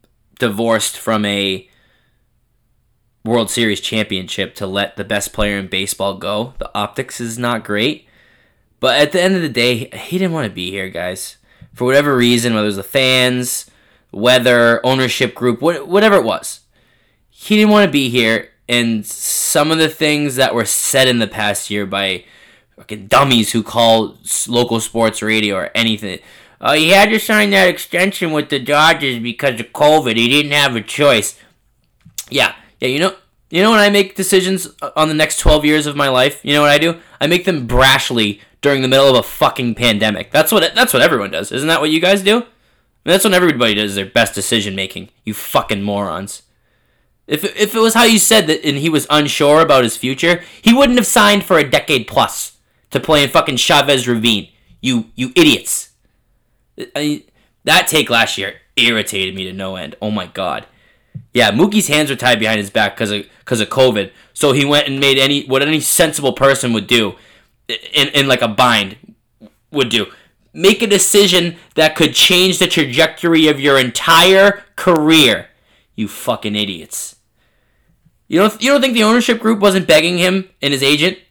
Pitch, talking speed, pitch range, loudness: 130 Hz, 190 wpm, 115-160 Hz, -13 LUFS